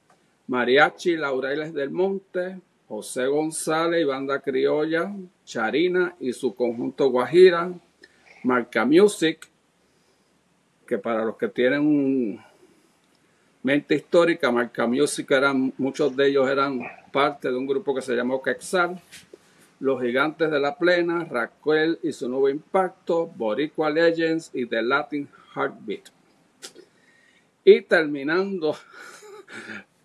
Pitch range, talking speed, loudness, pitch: 135-175 Hz, 110 wpm, -23 LUFS, 150 Hz